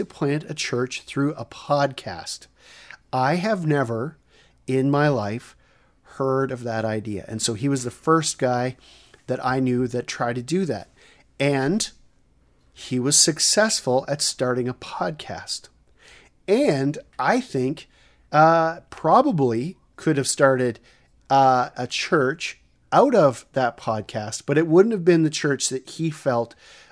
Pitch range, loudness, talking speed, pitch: 125-150 Hz, -22 LUFS, 145 wpm, 130 Hz